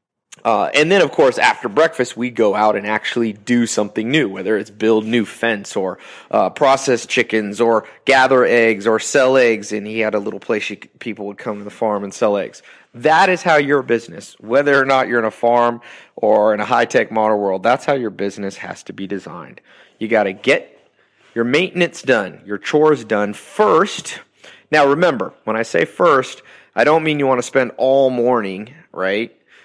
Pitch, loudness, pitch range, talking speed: 115 Hz, -16 LUFS, 105-135 Hz, 200 wpm